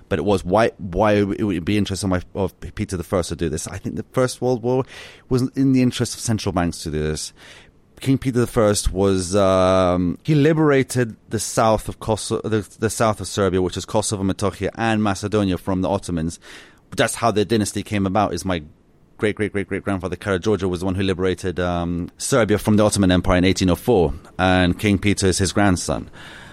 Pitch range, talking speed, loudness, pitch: 90-110 Hz, 200 wpm, -20 LUFS, 100 Hz